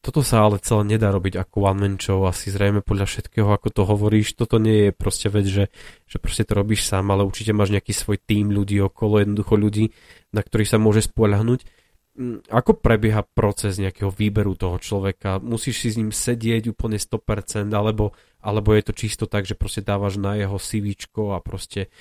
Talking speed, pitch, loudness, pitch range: 195 wpm, 105 Hz, -21 LUFS, 100-110 Hz